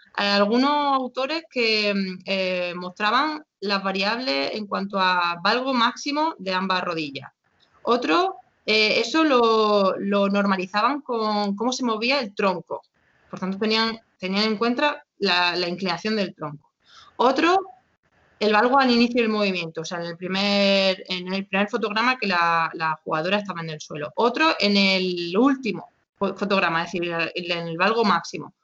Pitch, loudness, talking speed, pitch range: 200 Hz, -22 LUFS, 155 wpm, 180-235 Hz